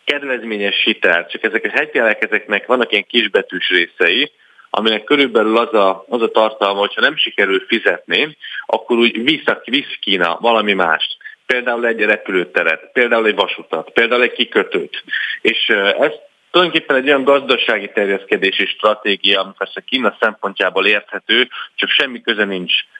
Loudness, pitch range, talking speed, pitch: -15 LUFS, 100-160 Hz, 145 wpm, 115 Hz